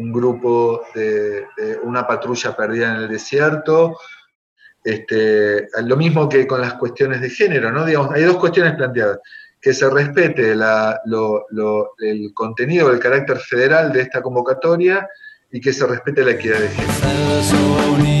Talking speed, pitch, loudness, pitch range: 155 wpm, 135 Hz, -17 LUFS, 115-170 Hz